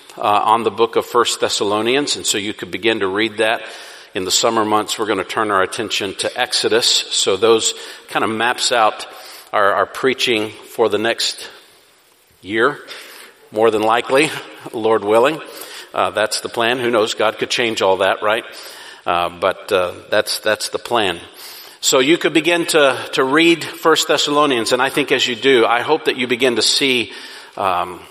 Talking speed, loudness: 185 wpm, -16 LUFS